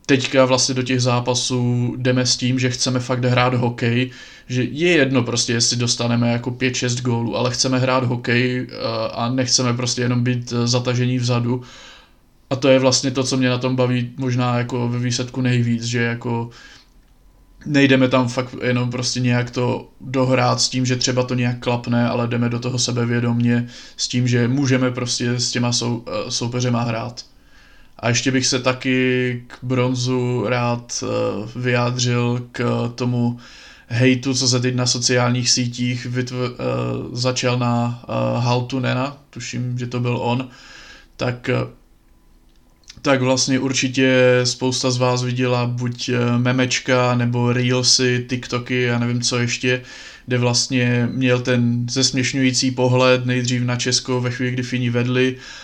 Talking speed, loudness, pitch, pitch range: 150 wpm, -19 LUFS, 125 Hz, 120-130 Hz